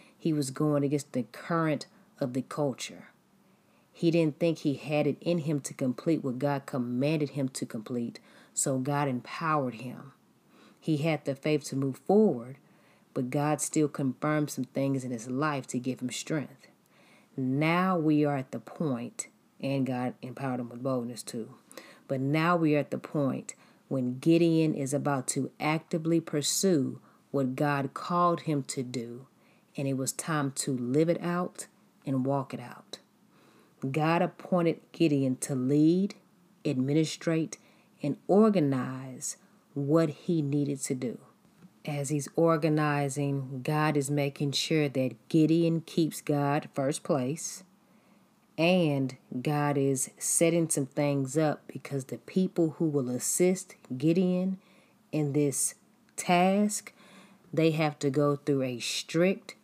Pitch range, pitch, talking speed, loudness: 135-170 Hz, 150 Hz, 145 wpm, -29 LUFS